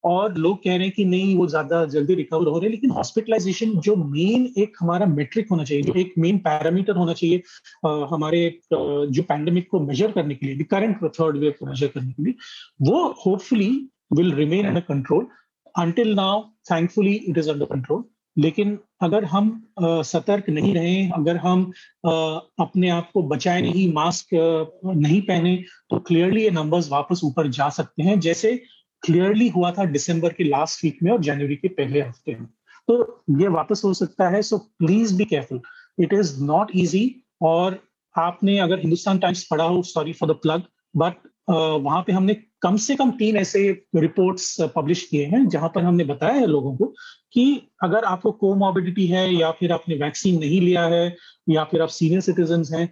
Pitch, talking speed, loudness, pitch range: 175 Hz, 160 wpm, -21 LUFS, 160-200 Hz